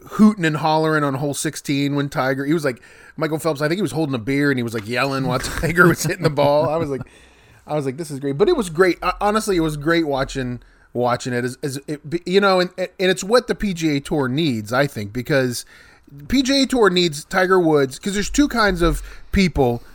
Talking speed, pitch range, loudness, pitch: 235 wpm, 135-180 Hz, -19 LUFS, 155 Hz